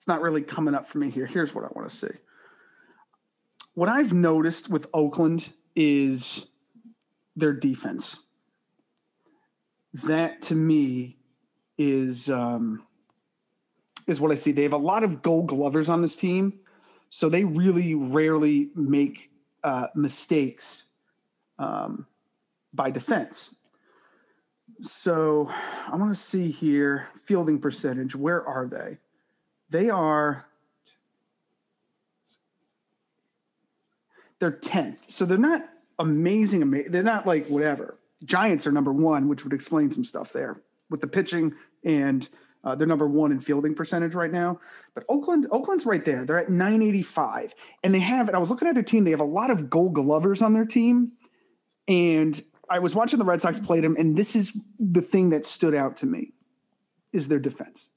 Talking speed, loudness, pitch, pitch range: 155 wpm, -24 LUFS, 170 Hz, 150-215 Hz